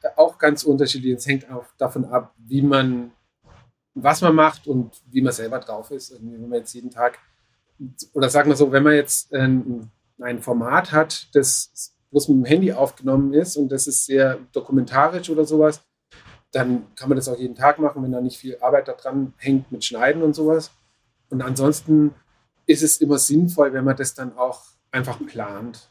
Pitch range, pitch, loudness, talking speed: 125-145 Hz, 135 Hz, -20 LUFS, 190 wpm